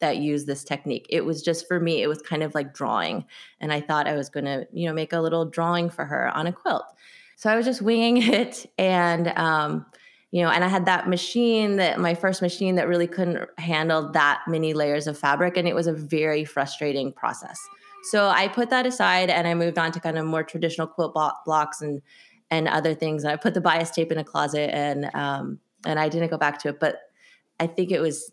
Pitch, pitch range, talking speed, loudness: 165 Hz, 150-180 Hz, 235 wpm, -24 LUFS